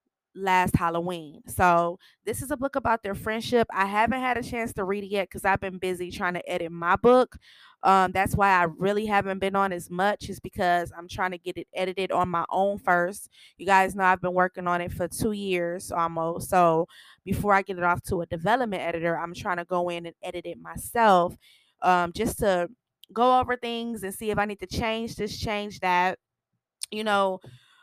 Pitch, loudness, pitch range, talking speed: 190 Hz, -26 LUFS, 175-205 Hz, 215 wpm